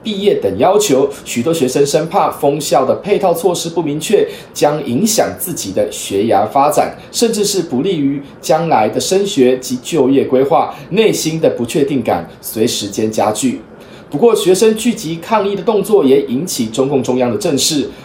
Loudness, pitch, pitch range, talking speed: -14 LUFS, 170 Hz, 135-215 Hz, 265 characters per minute